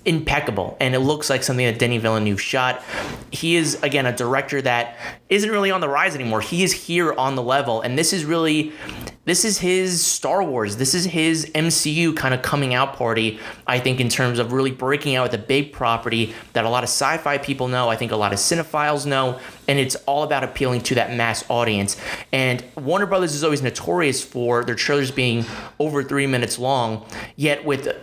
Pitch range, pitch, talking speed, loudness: 120-150 Hz, 130 Hz, 210 wpm, -20 LUFS